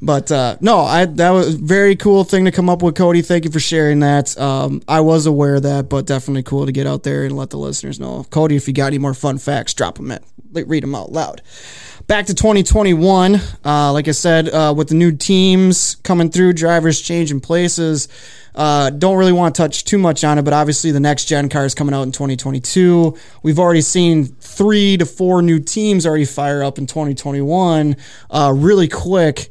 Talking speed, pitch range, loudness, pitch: 220 wpm, 140-175 Hz, -14 LUFS, 155 Hz